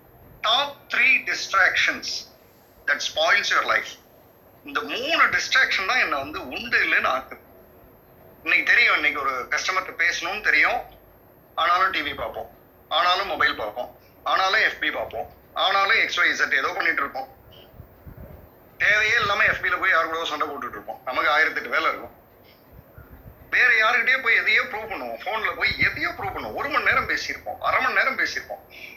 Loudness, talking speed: -21 LUFS, 130 wpm